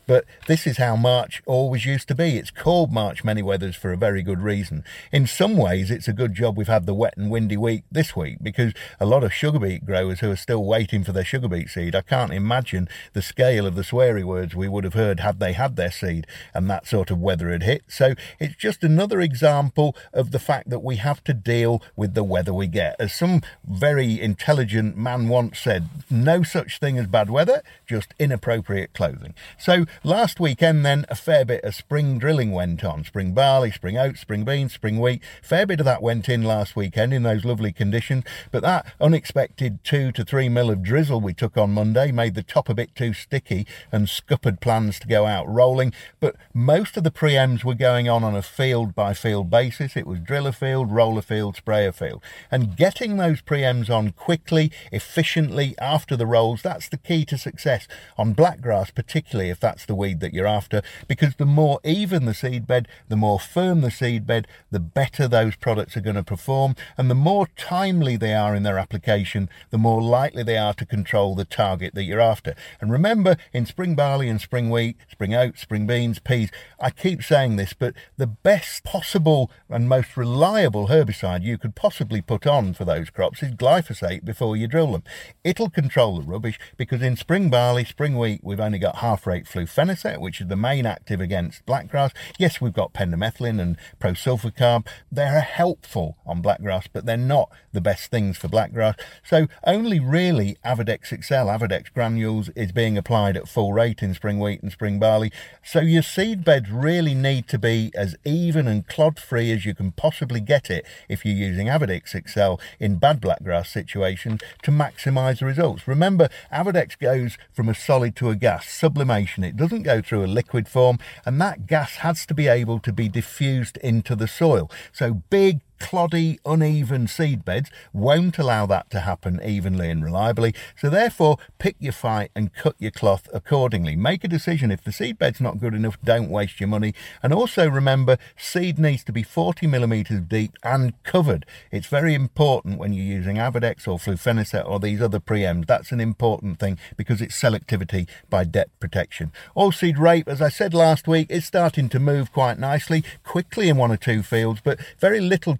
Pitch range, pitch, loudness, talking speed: 105-145 Hz, 120 Hz, -22 LUFS, 200 wpm